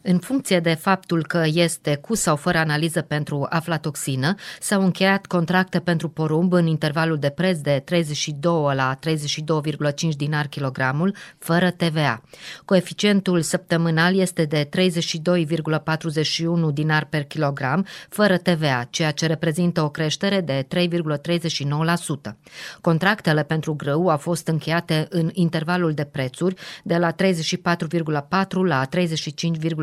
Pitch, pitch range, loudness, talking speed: 165 Hz, 155-180 Hz, -22 LUFS, 125 wpm